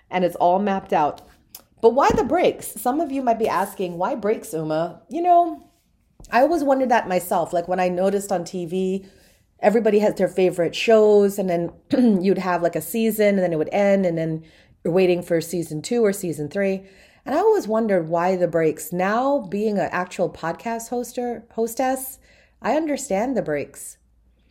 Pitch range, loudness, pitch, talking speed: 175-230 Hz, -21 LUFS, 195 Hz, 185 wpm